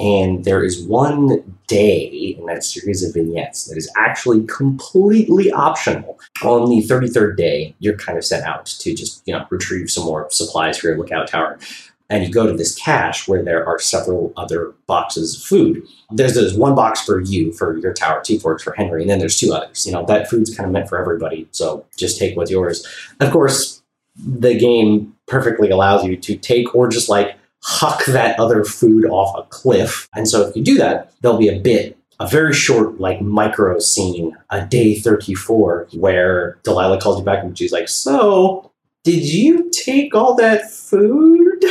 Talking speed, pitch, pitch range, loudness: 195 wpm, 105 Hz, 95-125 Hz, -16 LUFS